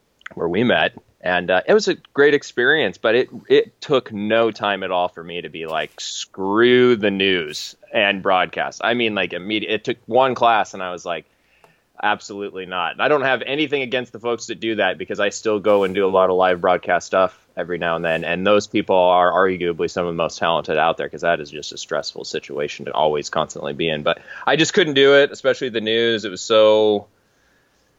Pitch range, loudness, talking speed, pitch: 90-115 Hz, -19 LUFS, 225 wpm, 105 Hz